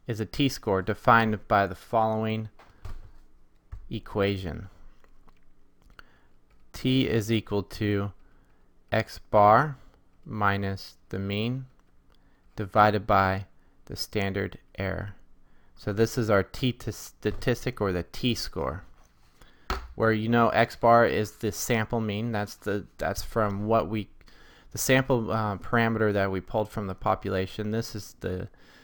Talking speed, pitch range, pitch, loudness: 120 wpm, 95-115 Hz, 105 Hz, -27 LUFS